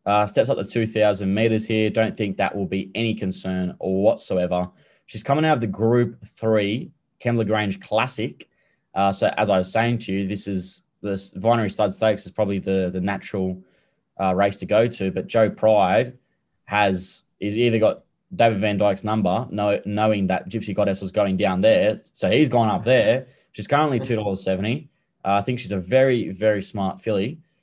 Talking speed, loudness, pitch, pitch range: 185 wpm, -22 LUFS, 105 Hz, 95-115 Hz